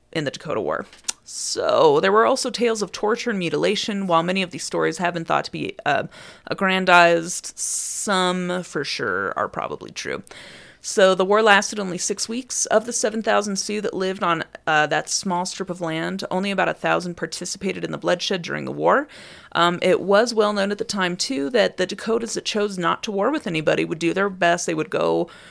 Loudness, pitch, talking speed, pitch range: -21 LUFS, 190 Hz, 210 wpm, 175-210 Hz